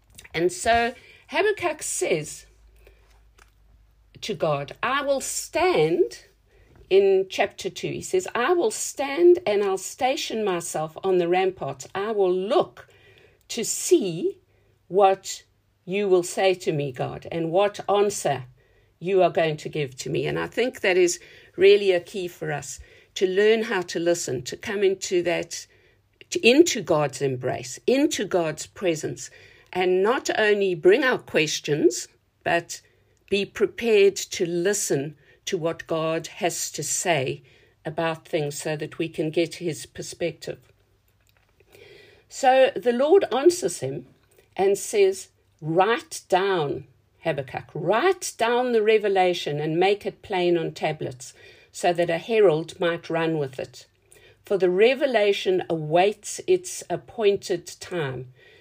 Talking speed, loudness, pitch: 135 wpm, -23 LUFS, 195 Hz